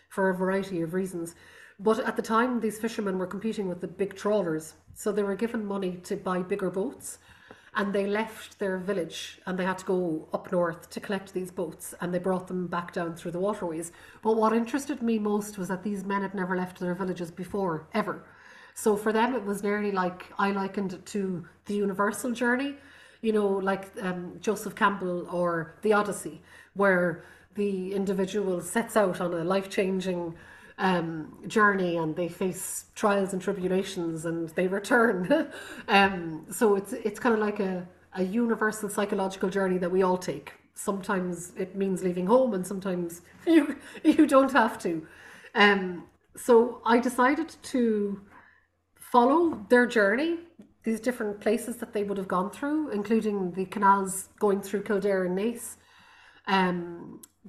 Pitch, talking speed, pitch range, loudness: 200 Hz, 170 wpm, 185-220 Hz, -28 LUFS